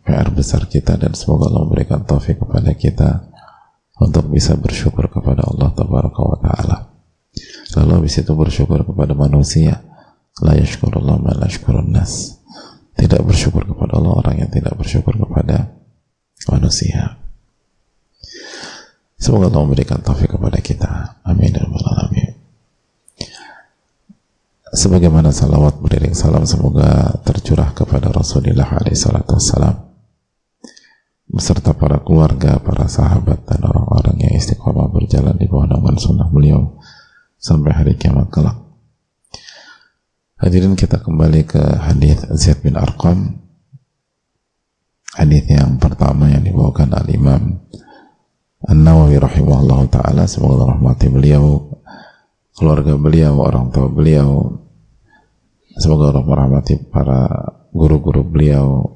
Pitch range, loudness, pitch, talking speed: 70-80 Hz, -14 LUFS, 75 Hz, 105 wpm